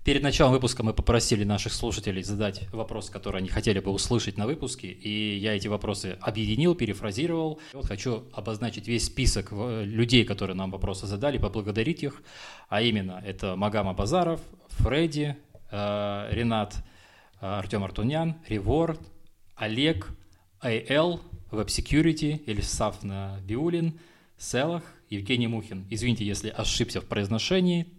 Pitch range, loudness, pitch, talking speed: 100-130 Hz, -28 LUFS, 110 Hz, 125 wpm